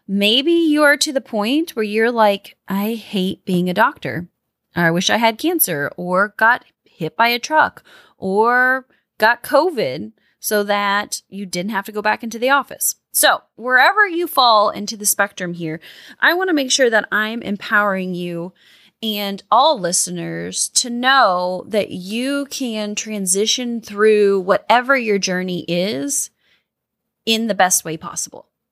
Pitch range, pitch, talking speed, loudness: 190-245 Hz, 210 Hz, 160 wpm, -17 LUFS